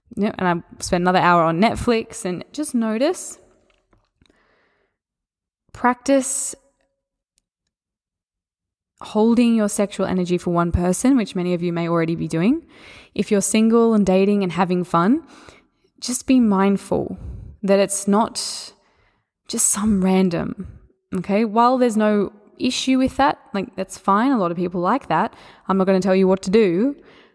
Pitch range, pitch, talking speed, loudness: 180-240 Hz, 200 Hz, 150 wpm, -19 LUFS